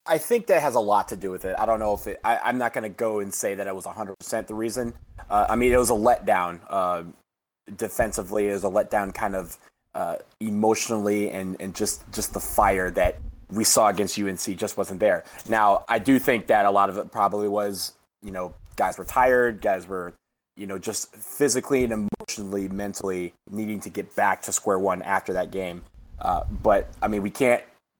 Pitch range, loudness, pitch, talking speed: 95-110 Hz, -25 LUFS, 100 Hz, 215 wpm